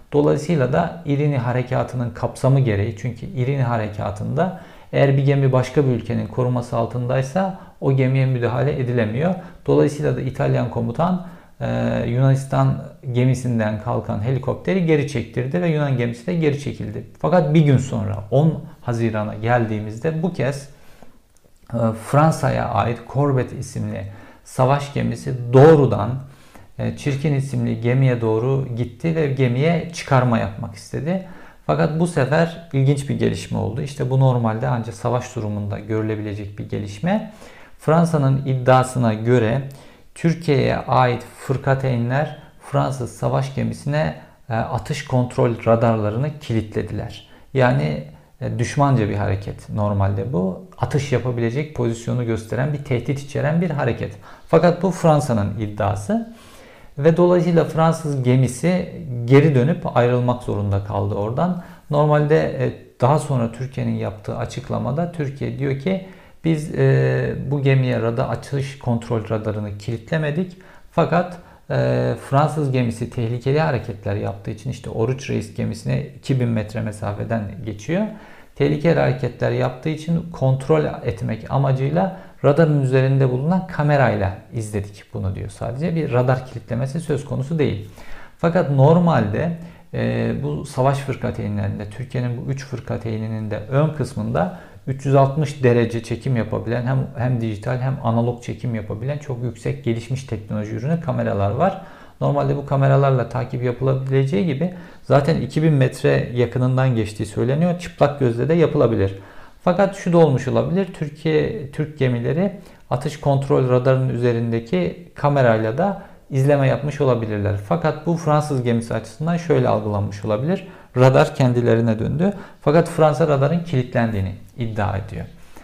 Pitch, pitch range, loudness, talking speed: 130 Hz, 115-150 Hz, -20 LUFS, 125 wpm